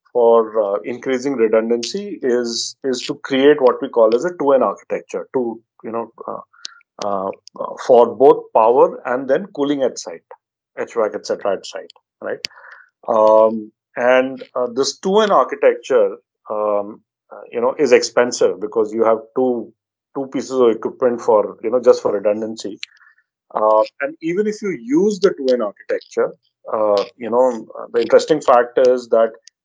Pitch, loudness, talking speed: 190 Hz, -17 LUFS, 160 wpm